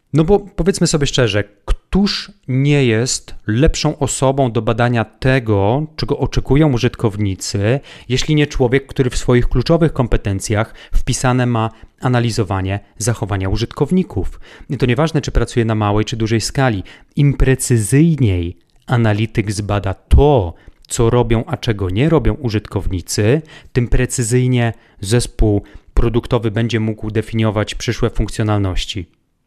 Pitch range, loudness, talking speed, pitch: 105-135 Hz, -17 LUFS, 120 wpm, 120 Hz